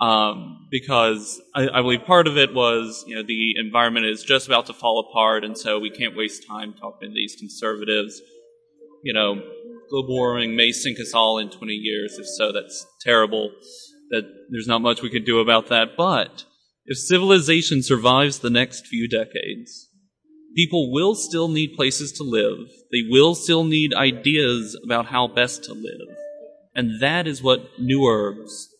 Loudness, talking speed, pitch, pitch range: -20 LUFS, 175 wpm, 125 Hz, 115-155 Hz